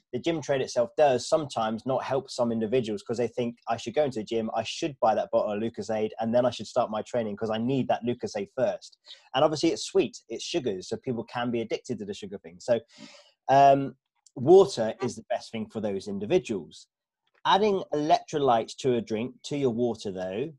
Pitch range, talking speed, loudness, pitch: 110-145 Hz, 220 wpm, -27 LUFS, 120 Hz